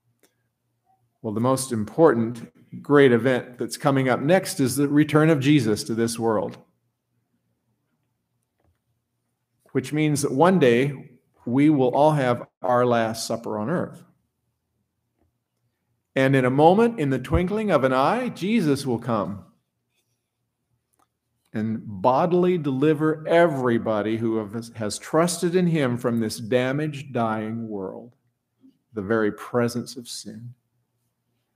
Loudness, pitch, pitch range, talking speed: -22 LUFS, 125 Hz, 115-145 Hz, 125 wpm